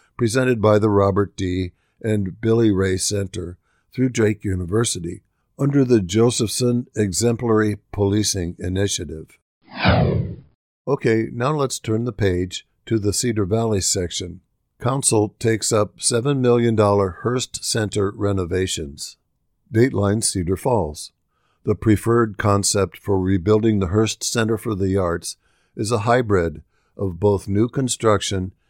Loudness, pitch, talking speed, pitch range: -20 LUFS, 105 Hz, 120 wpm, 95-115 Hz